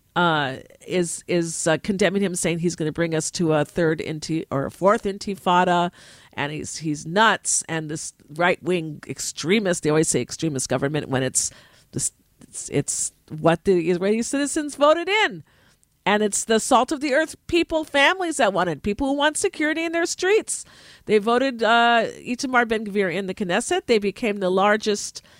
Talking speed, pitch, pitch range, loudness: 180 wpm, 195 Hz, 165-240 Hz, -22 LUFS